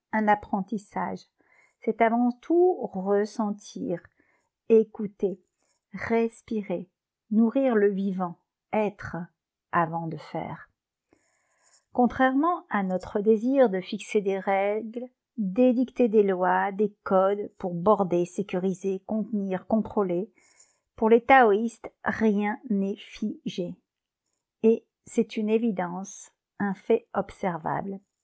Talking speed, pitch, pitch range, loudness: 100 wpm, 215 Hz, 195-230 Hz, -26 LUFS